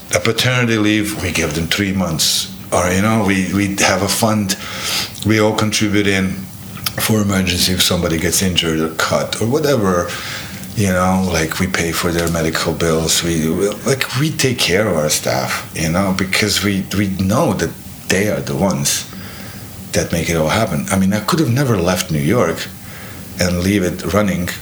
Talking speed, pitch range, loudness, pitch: 190 wpm, 85-105 Hz, -16 LUFS, 95 Hz